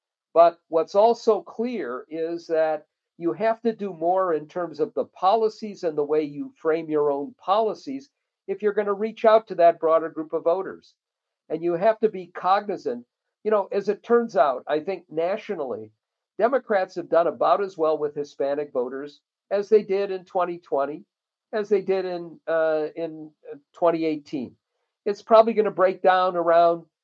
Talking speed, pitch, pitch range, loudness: 175 wpm, 175 Hz, 160-210 Hz, -24 LUFS